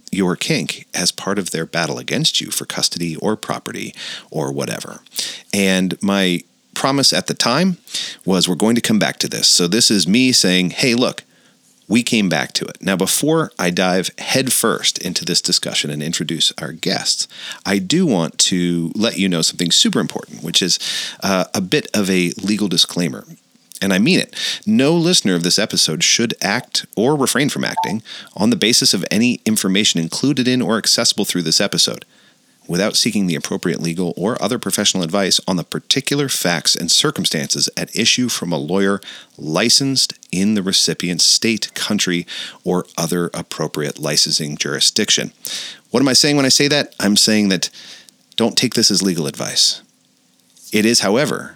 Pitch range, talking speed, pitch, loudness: 90-125 Hz, 175 wpm, 100 Hz, -16 LUFS